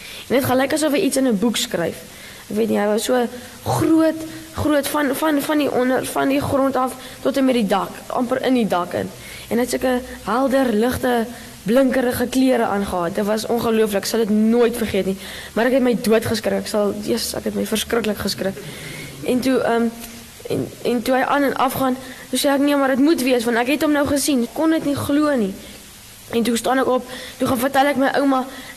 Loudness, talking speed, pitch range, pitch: -19 LUFS, 225 wpm, 220-265 Hz, 245 Hz